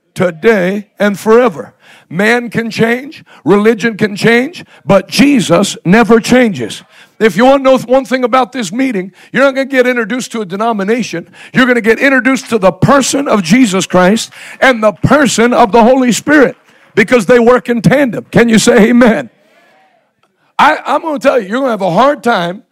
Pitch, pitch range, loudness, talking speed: 235 Hz, 205-255 Hz, -10 LUFS, 190 wpm